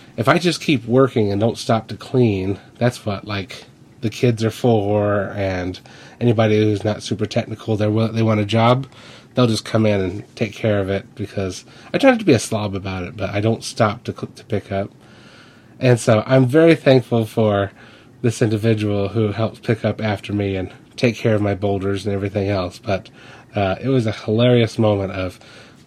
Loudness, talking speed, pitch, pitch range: -19 LUFS, 195 wpm, 110 Hz, 100-120 Hz